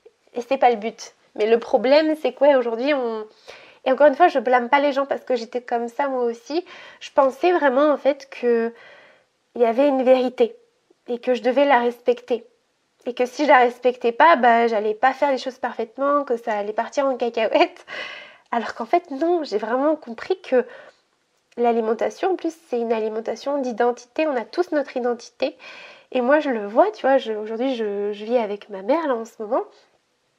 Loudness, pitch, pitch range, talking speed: -21 LUFS, 260 Hz, 235-295 Hz, 205 wpm